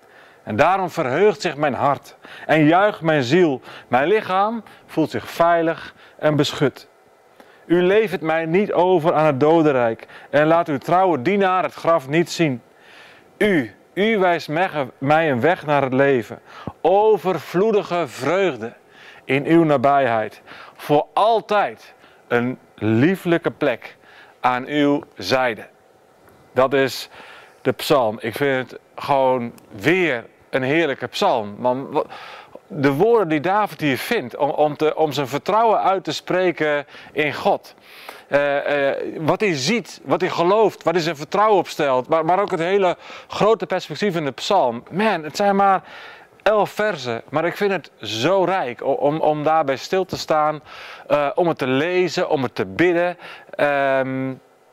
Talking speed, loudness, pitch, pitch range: 150 wpm, -19 LUFS, 155 Hz, 140-185 Hz